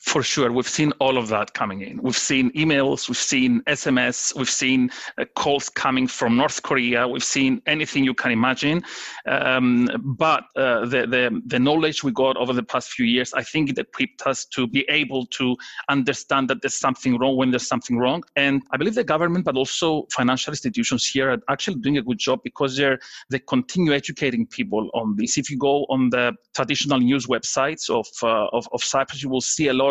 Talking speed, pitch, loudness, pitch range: 205 wpm, 135 Hz, -21 LUFS, 130-155 Hz